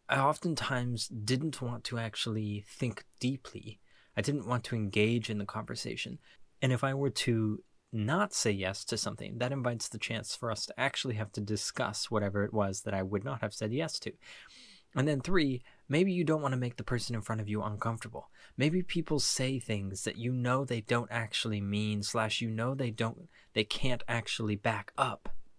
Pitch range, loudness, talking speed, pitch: 110-130 Hz, -33 LUFS, 200 wpm, 115 Hz